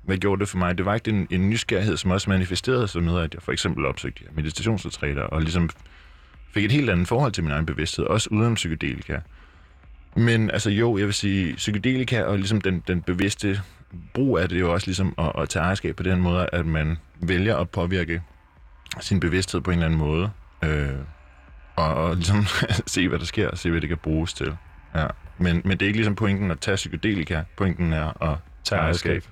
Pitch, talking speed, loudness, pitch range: 90 Hz, 215 wpm, -24 LUFS, 80-100 Hz